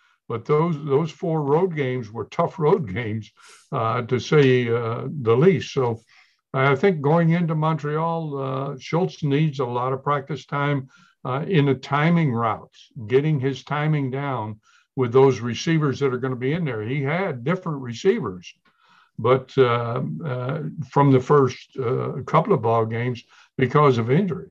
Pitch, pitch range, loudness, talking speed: 140 Hz, 125-155 Hz, -22 LUFS, 165 wpm